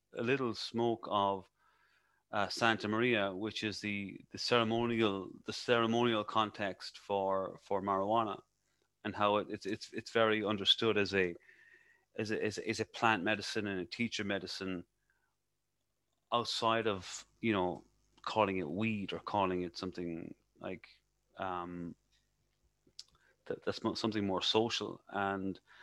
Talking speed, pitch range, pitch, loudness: 130 wpm, 95-110 Hz, 105 Hz, -35 LUFS